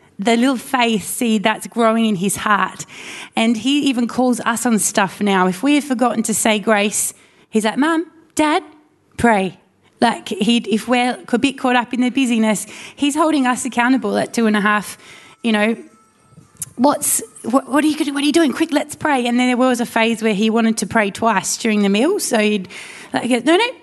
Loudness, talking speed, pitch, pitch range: -17 LUFS, 210 wpm, 235 Hz, 220-275 Hz